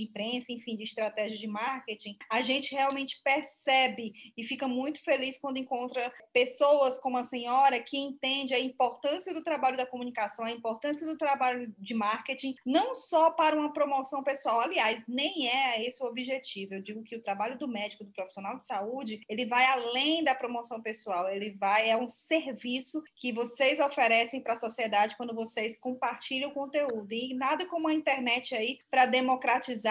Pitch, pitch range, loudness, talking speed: 250 Hz, 225-275 Hz, -30 LUFS, 175 wpm